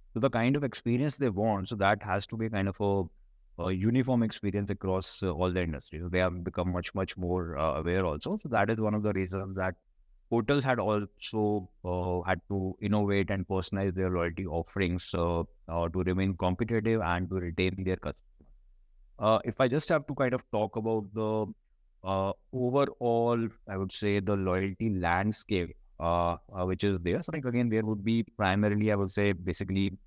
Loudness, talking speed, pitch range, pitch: -30 LUFS, 195 wpm, 90-110 Hz, 95 Hz